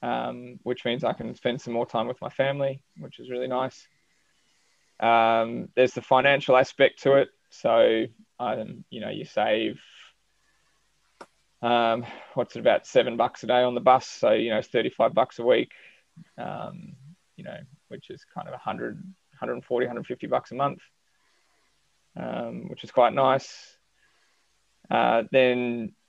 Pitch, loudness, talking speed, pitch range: 125 Hz, -25 LUFS, 155 wpm, 115-140 Hz